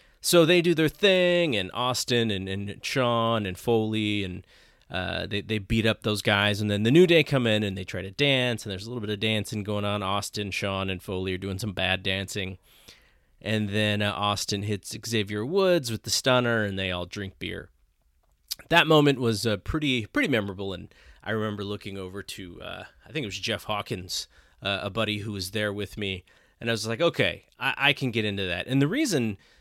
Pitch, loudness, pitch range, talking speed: 105 Hz, -26 LUFS, 100-120 Hz, 215 wpm